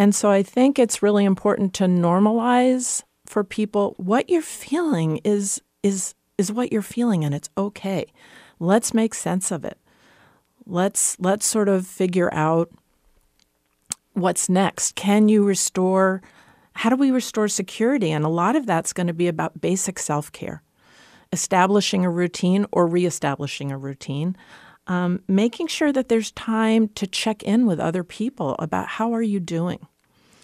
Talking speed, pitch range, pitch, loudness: 160 wpm, 175-220 Hz, 195 Hz, -21 LUFS